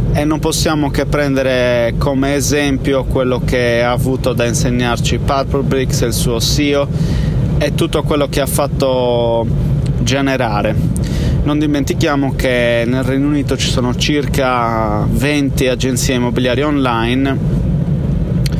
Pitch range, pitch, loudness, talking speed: 125-145 Hz, 135 Hz, -15 LUFS, 125 wpm